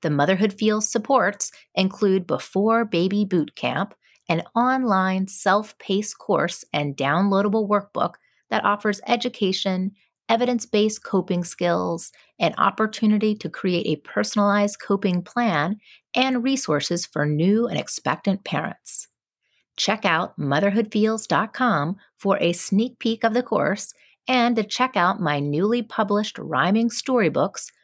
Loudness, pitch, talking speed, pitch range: -22 LUFS, 205 Hz, 125 wpm, 180-230 Hz